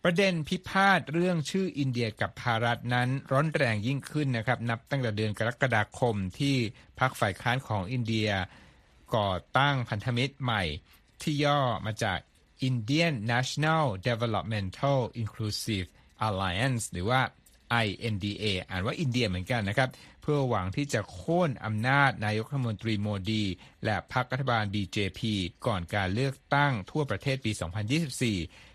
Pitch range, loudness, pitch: 105-135 Hz, -29 LUFS, 120 Hz